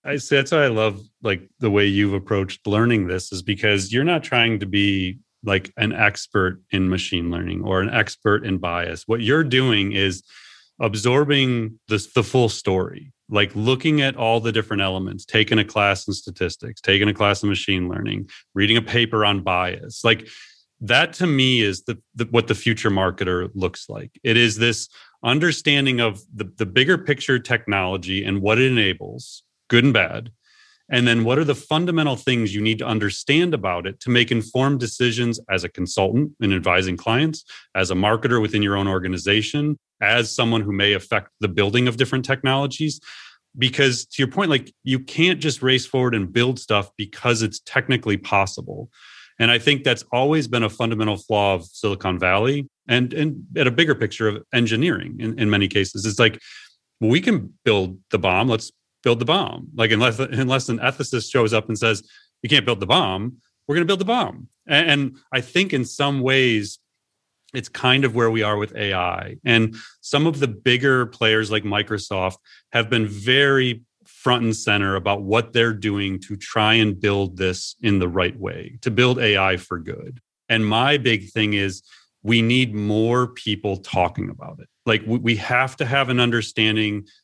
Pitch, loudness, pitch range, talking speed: 110 Hz, -20 LUFS, 100-130 Hz, 190 wpm